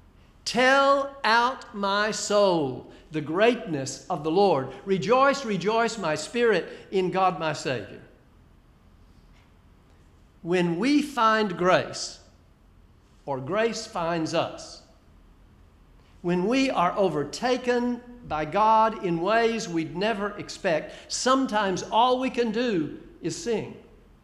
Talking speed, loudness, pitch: 105 wpm, -25 LUFS, 185 Hz